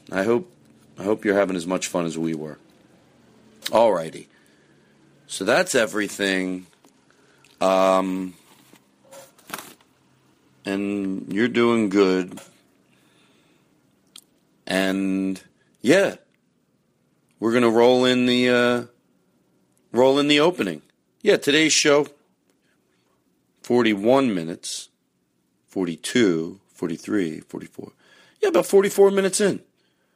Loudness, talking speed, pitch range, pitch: -21 LUFS, 95 wpm, 90-125 Hz, 100 Hz